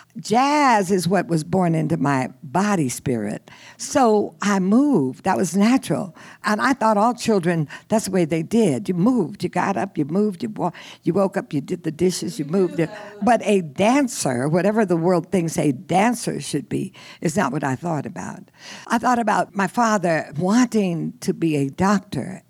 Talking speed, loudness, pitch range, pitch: 180 wpm, -21 LUFS, 165-210 Hz, 190 Hz